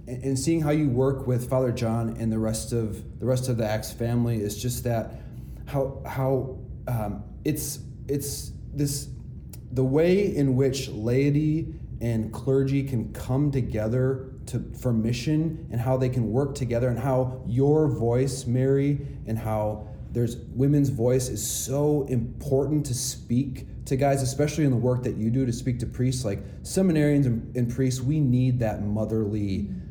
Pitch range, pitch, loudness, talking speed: 115-135 Hz, 125 Hz, -26 LUFS, 165 wpm